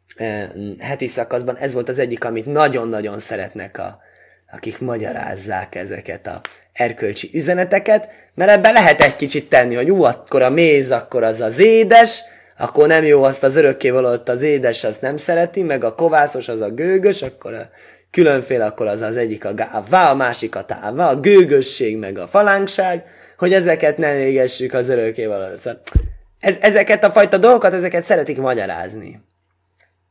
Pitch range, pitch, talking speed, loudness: 120-195 Hz, 145 Hz, 160 wpm, -15 LUFS